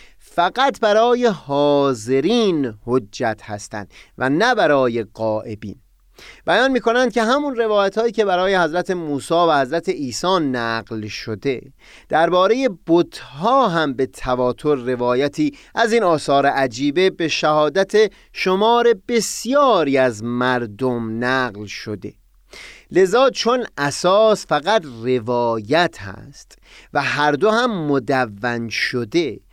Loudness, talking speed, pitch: -18 LUFS, 110 wpm, 145 Hz